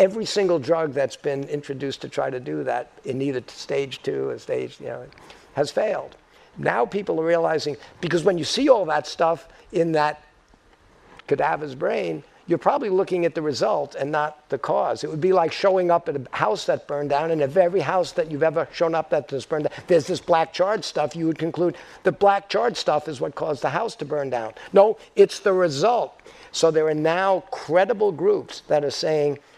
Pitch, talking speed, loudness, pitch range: 165 Hz, 210 wpm, -23 LUFS, 150-190 Hz